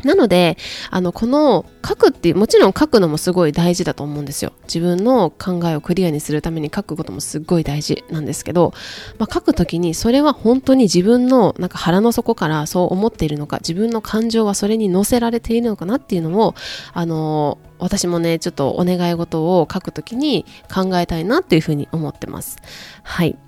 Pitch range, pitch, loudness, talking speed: 160-225 Hz, 180 Hz, -17 LUFS, 415 characters per minute